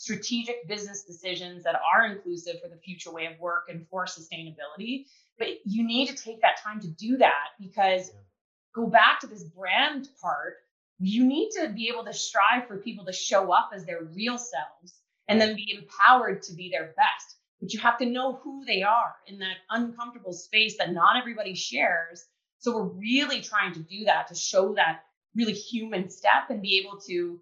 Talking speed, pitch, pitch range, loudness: 195 wpm, 205 Hz, 180-235 Hz, -26 LUFS